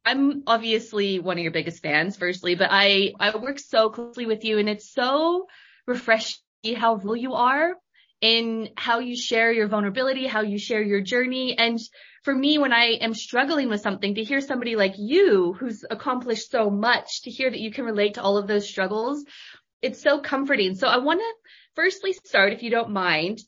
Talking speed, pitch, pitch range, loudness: 195 wpm, 230 Hz, 210-265 Hz, -23 LUFS